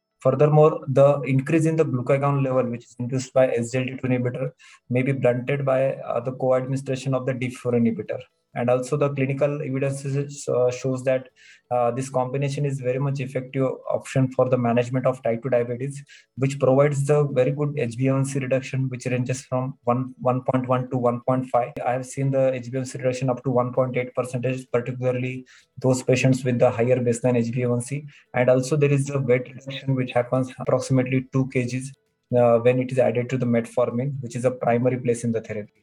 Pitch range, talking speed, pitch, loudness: 125-135 Hz, 180 wpm, 130 Hz, -23 LUFS